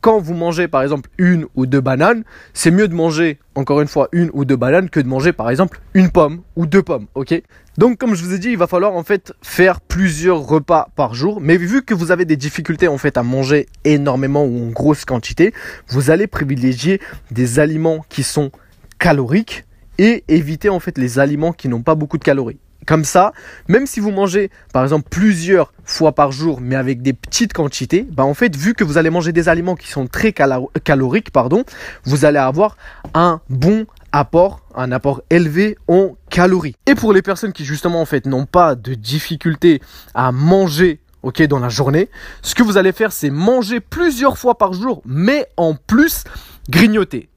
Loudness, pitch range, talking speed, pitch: -15 LUFS, 140-190 Hz, 200 wpm, 165 Hz